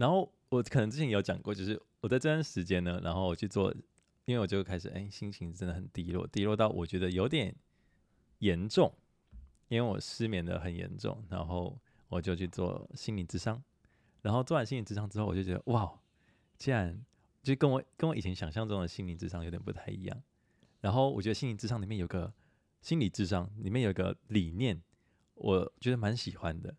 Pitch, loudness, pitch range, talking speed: 100 Hz, -35 LUFS, 90-115 Hz, 300 characters per minute